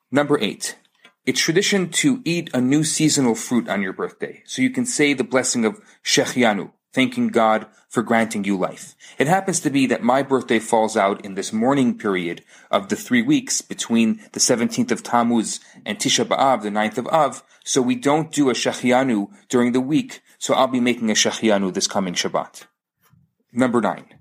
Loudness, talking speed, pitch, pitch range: -20 LUFS, 190 wpm, 130 Hz, 115-175 Hz